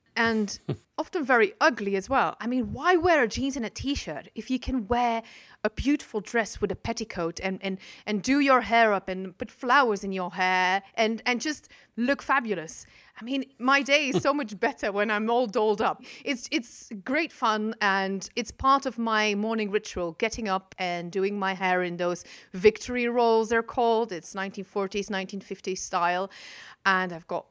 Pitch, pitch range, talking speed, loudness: 220 Hz, 195-250 Hz, 190 wpm, -26 LUFS